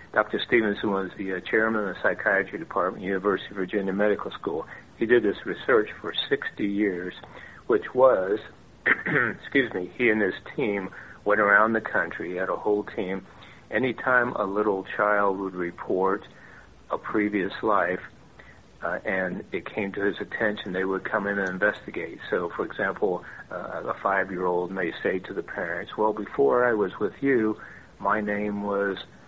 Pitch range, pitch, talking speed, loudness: 95-105 Hz, 100 Hz, 170 wpm, -26 LUFS